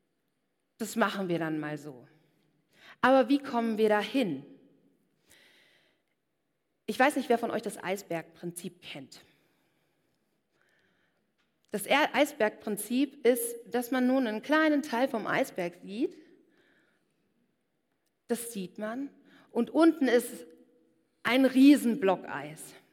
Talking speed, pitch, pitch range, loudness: 110 wpm, 235 Hz, 195-270 Hz, -28 LUFS